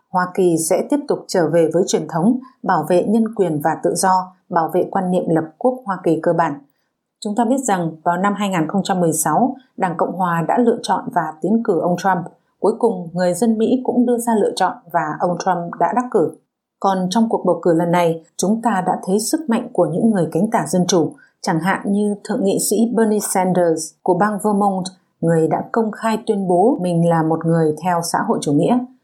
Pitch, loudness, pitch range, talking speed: 185 Hz, -18 LUFS, 170-225 Hz, 220 wpm